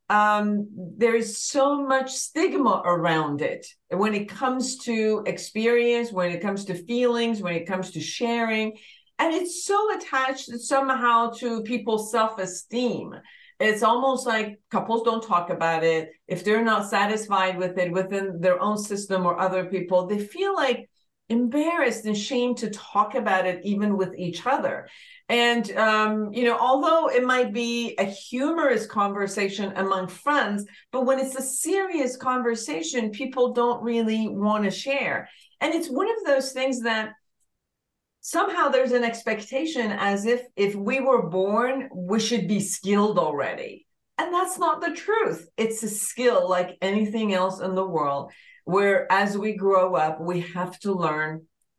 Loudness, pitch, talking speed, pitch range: -24 LUFS, 220 Hz, 160 wpm, 195-260 Hz